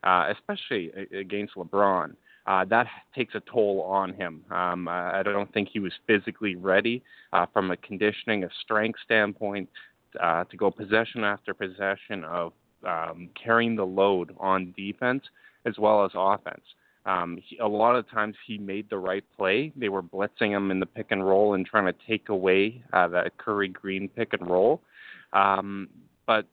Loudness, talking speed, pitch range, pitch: -27 LUFS, 175 wpm, 95-110 Hz, 100 Hz